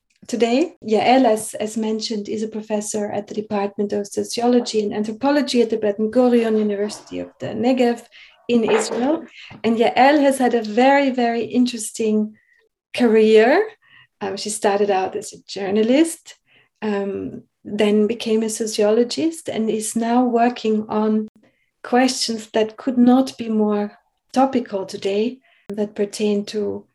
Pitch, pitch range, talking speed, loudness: 220 Hz, 210-245 Hz, 135 wpm, -19 LUFS